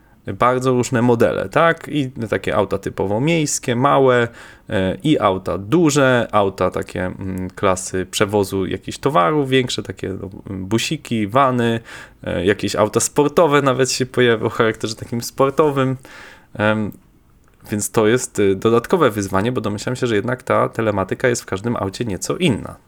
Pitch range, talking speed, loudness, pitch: 100-130 Hz, 135 wpm, -18 LUFS, 115 Hz